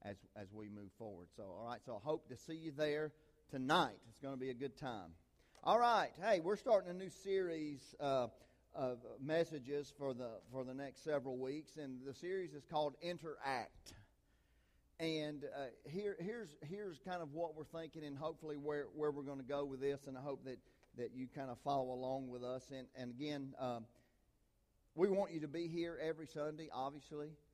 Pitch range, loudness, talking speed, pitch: 130-155 Hz, -43 LUFS, 200 wpm, 145 Hz